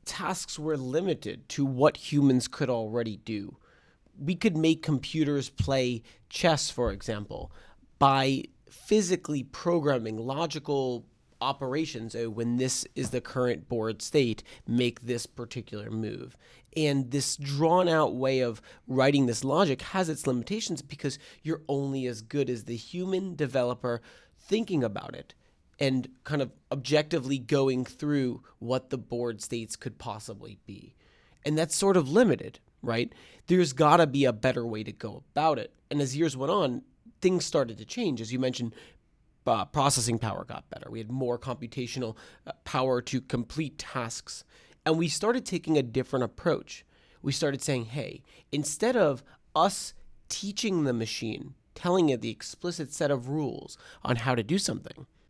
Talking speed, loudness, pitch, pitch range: 155 wpm, -29 LUFS, 135 Hz, 120-155 Hz